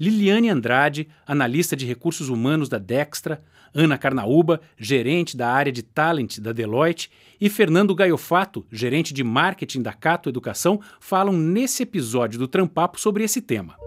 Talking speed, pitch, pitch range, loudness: 145 wpm, 160 Hz, 130-185 Hz, -21 LUFS